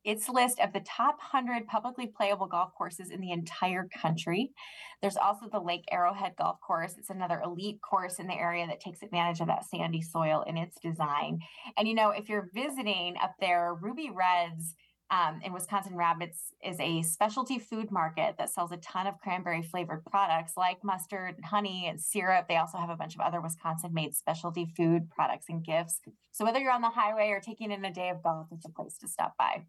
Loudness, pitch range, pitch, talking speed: -32 LUFS, 170-205 Hz, 180 Hz, 210 wpm